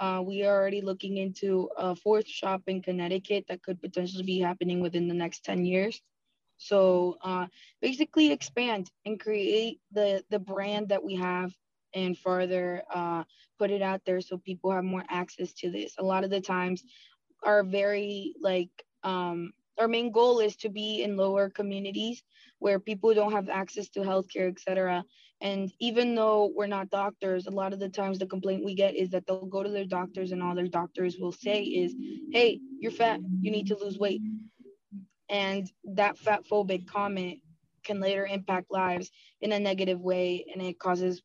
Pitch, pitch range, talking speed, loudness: 195 Hz, 185-205 Hz, 185 wpm, -30 LUFS